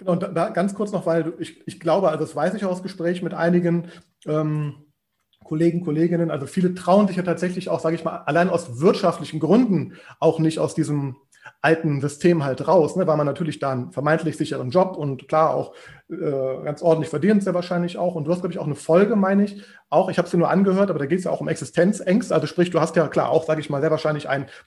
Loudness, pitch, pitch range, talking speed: -21 LUFS, 165 Hz, 150-180 Hz, 240 wpm